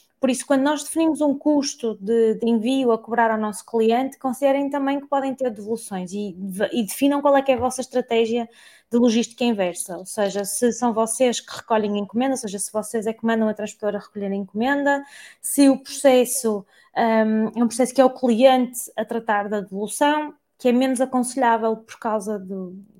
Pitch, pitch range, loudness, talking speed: 235 Hz, 215-265 Hz, -21 LUFS, 200 wpm